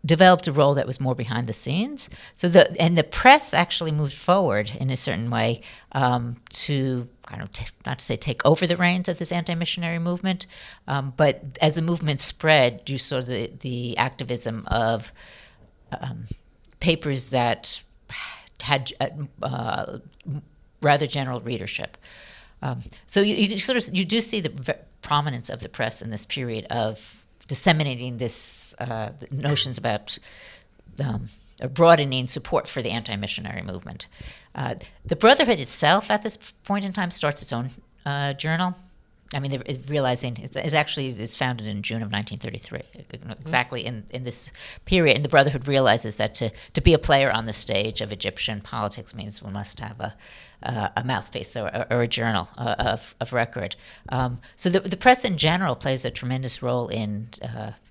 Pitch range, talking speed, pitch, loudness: 115-155 Hz, 170 wpm, 130 Hz, -23 LUFS